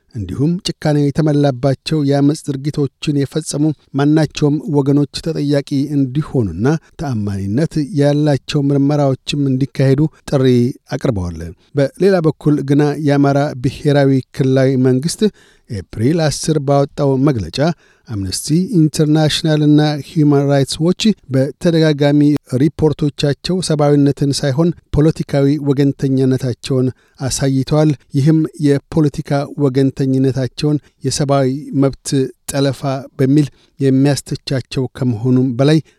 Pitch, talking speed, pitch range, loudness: 140 Hz, 85 wpm, 135-150 Hz, -15 LUFS